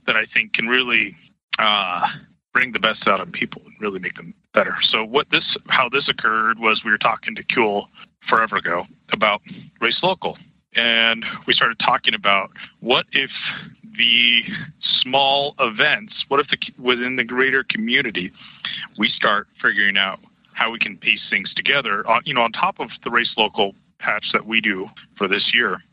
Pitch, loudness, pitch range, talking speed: 125 Hz, -19 LUFS, 115-140 Hz, 175 wpm